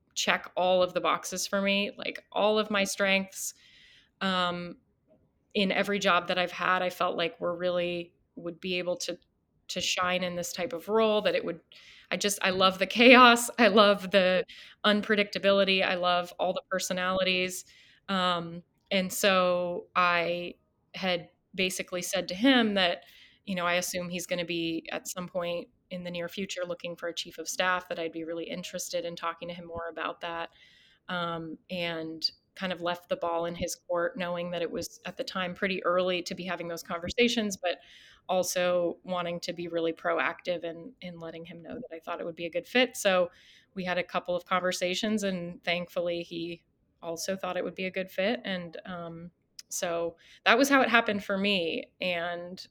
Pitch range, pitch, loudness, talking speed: 175-190 Hz, 180 Hz, -28 LUFS, 195 wpm